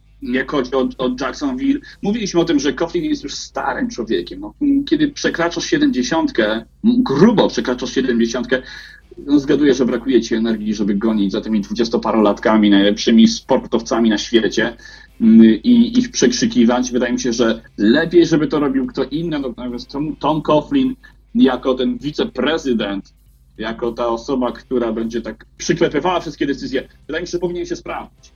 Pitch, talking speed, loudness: 130 Hz, 150 wpm, -17 LUFS